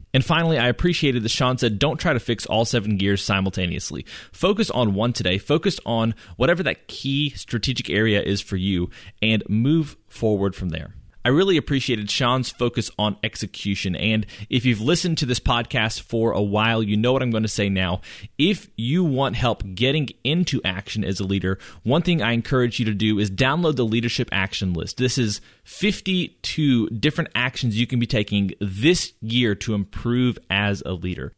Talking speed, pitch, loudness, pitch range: 185 wpm, 115 Hz, -22 LUFS, 100-130 Hz